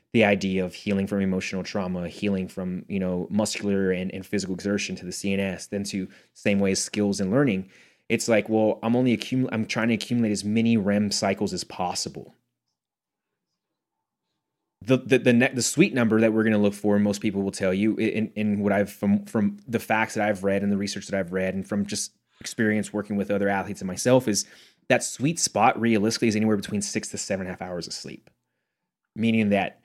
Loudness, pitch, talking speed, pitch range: -25 LUFS, 100 Hz, 215 wpm, 95-110 Hz